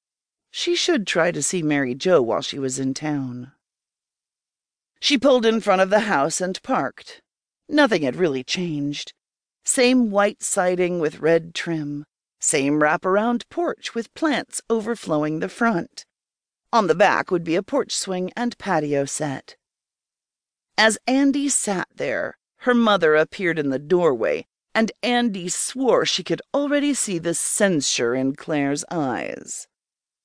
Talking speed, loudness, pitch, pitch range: 145 wpm, -21 LUFS, 185 Hz, 150-235 Hz